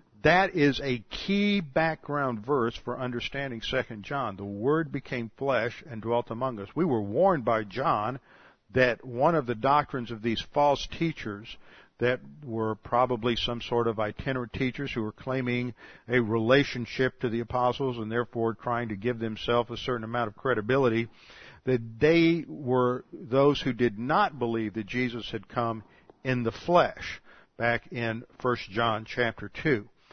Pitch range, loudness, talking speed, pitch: 115-130 Hz, -28 LUFS, 160 wpm, 120 Hz